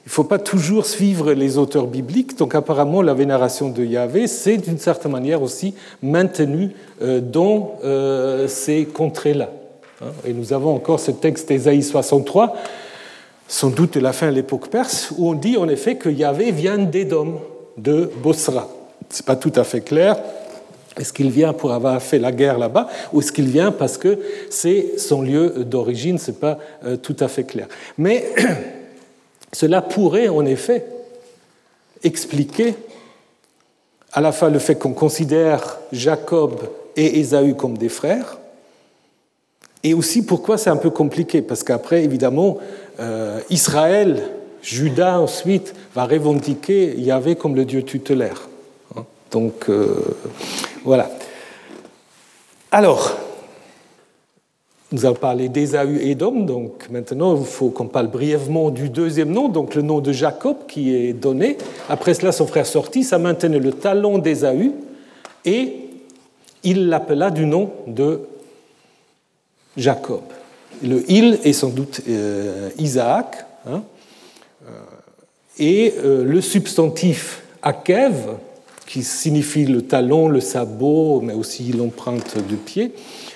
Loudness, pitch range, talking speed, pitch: -18 LUFS, 135-185 Hz, 135 wpm, 155 Hz